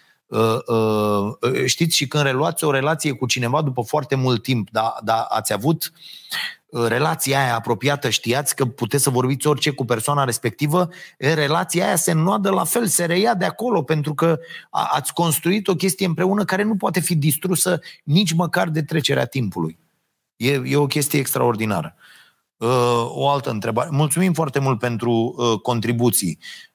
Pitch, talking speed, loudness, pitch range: 140 Hz, 170 wpm, -20 LUFS, 120-165 Hz